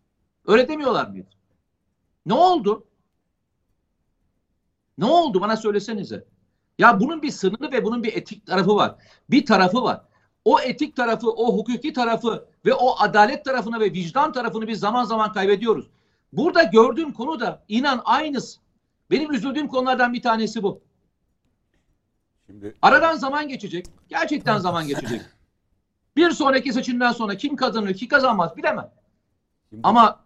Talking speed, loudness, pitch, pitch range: 130 wpm, -20 LUFS, 225 Hz, 185-260 Hz